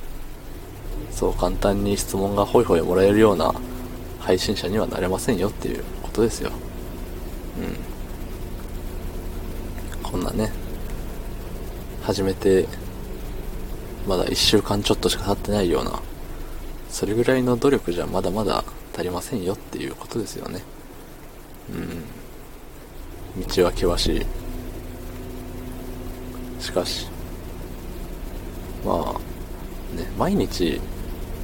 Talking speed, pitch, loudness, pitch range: 215 characters per minute, 90 Hz, -25 LUFS, 90-105 Hz